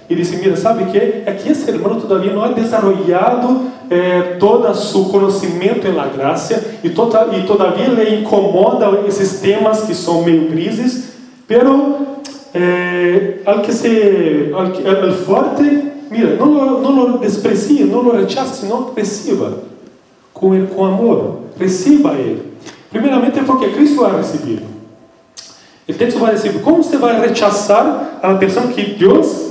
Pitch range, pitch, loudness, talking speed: 190-255 Hz, 215 Hz, -13 LUFS, 145 wpm